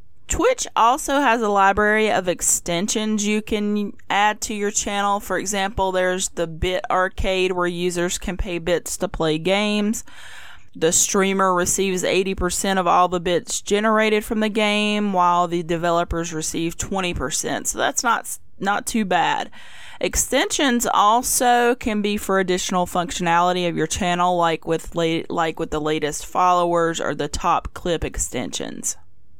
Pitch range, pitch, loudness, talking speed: 175-210 Hz, 185 Hz, -20 LUFS, 150 wpm